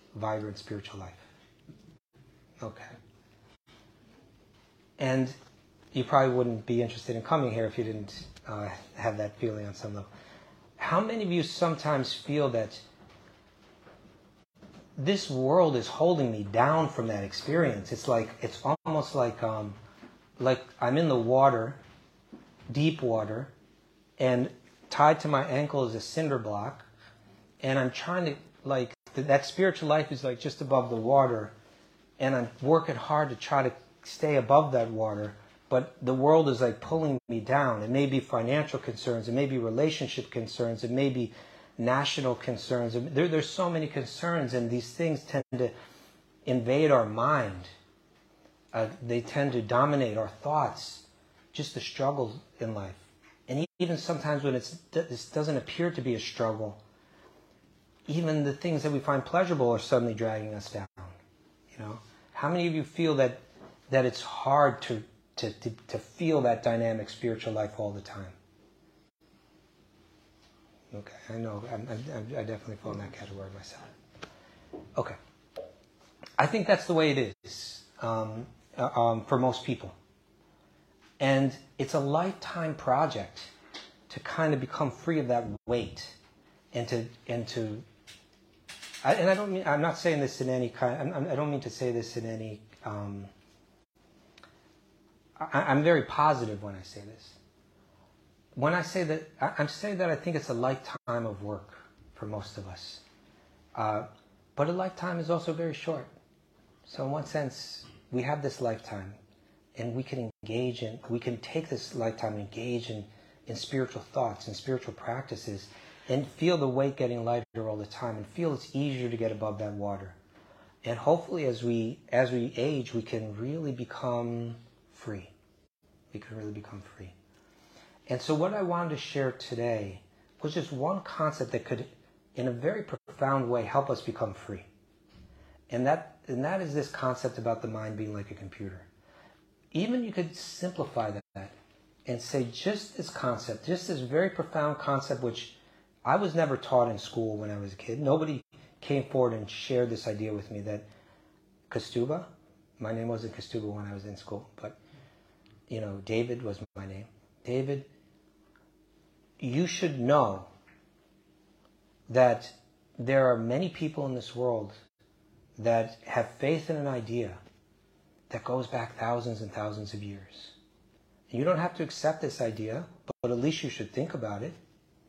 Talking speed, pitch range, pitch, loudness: 165 wpm, 110-145 Hz, 120 Hz, -31 LUFS